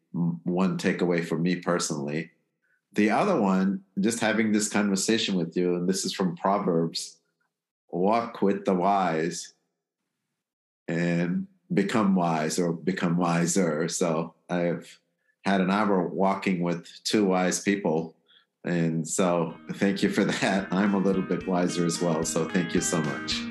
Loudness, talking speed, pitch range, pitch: -26 LUFS, 150 wpm, 85-95 Hz, 90 Hz